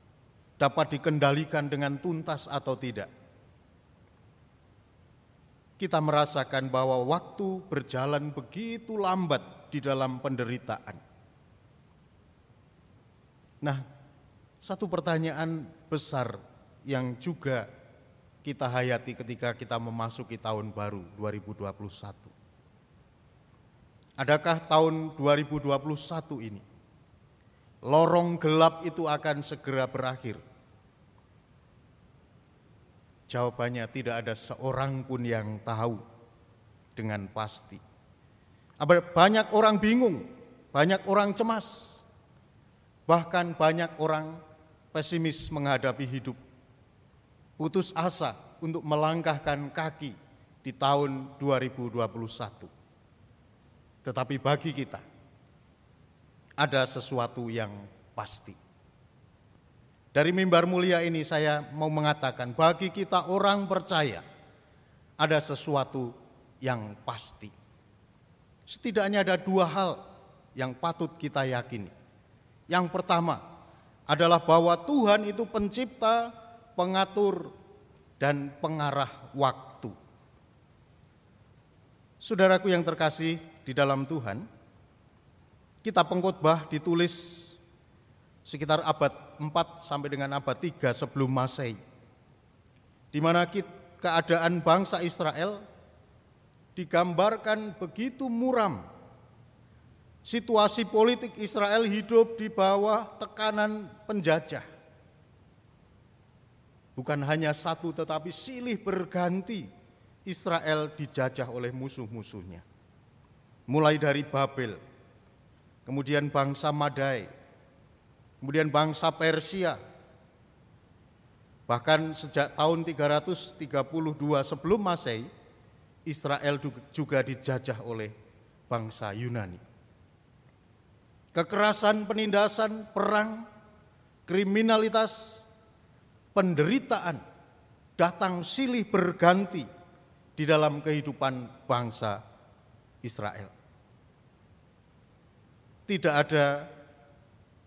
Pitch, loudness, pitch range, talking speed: 145 Hz, -29 LUFS, 125-170 Hz, 75 wpm